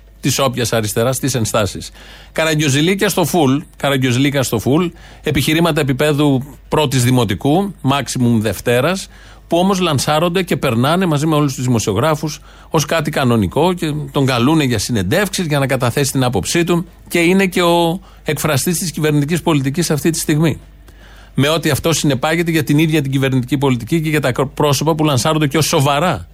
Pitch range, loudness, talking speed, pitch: 130-165 Hz, -15 LUFS, 160 wpm, 150 Hz